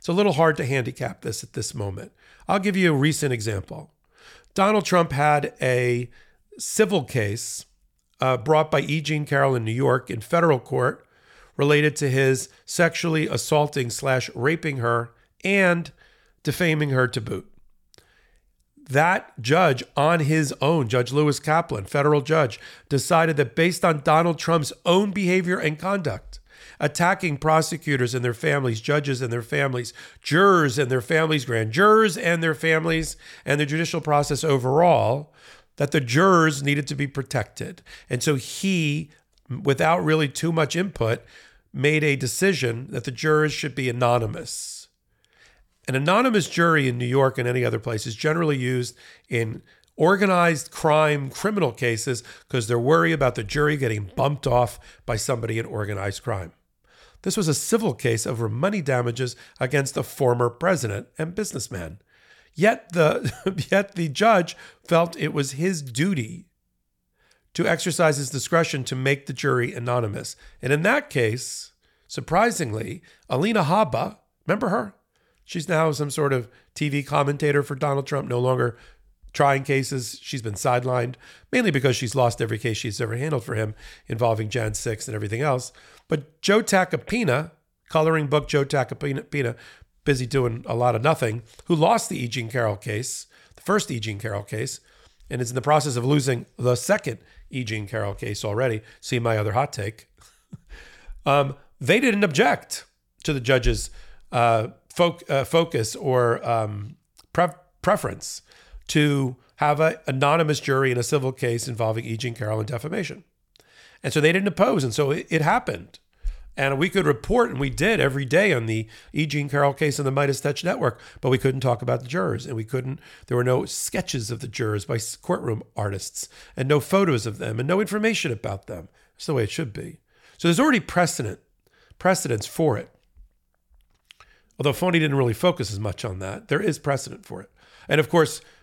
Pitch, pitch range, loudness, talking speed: 140 Hz, 120-160 Hz, -23 LUFS, 165 wpm